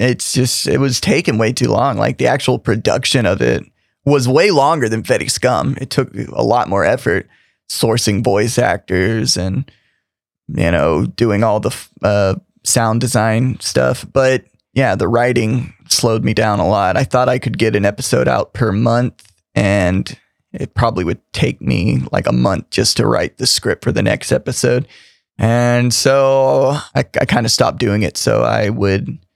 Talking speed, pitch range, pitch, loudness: 180 wpm, 100-125 Hz, 115 Hz, -15 LUFS